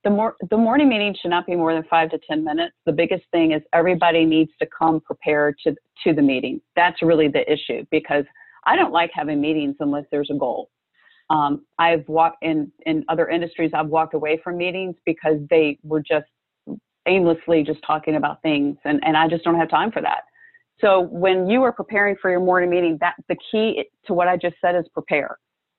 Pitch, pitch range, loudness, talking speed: 165 Hz, 155-185 Hz, -20 LUFS, 210 wpm